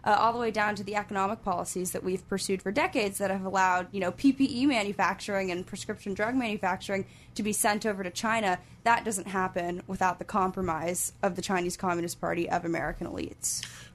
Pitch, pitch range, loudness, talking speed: 195 Hz, 180-210 Hz, -29 LUFS, 195 wpm